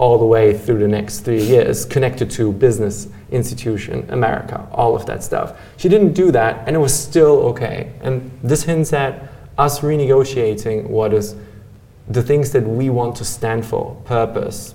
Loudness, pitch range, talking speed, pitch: -17 LUFS, 110-140 Hz, 175 wpm, 120 Hz